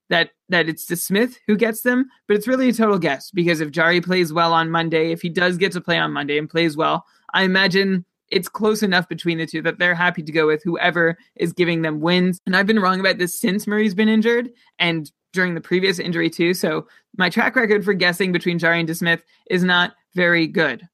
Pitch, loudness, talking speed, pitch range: 180 Hz, -19 LUFS, 235 wpm, 170-195 Hz